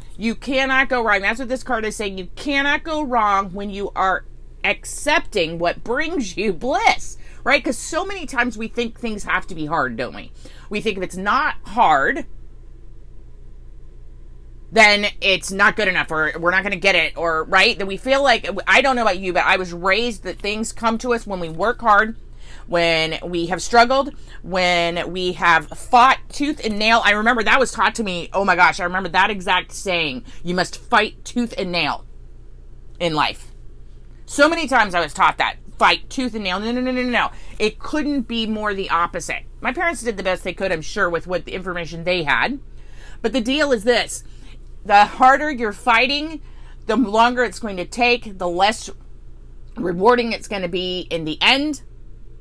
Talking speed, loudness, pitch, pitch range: 200 wpm, -19 LUFS, 205 Hz, 175-240 Hz